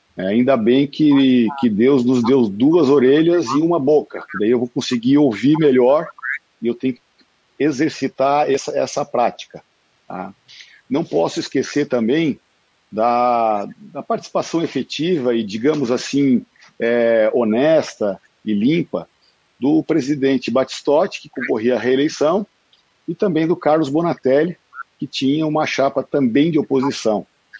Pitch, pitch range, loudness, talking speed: 135 Hz, 125-155 Hz, -17 LUFS, 135 wpm